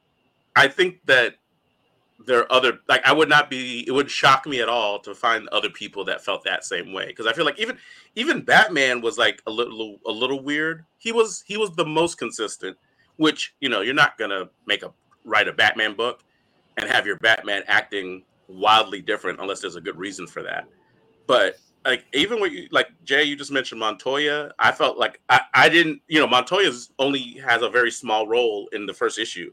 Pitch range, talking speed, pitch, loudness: 120-165 Hz, 210 wpm, 140 Hz, -21 LUFS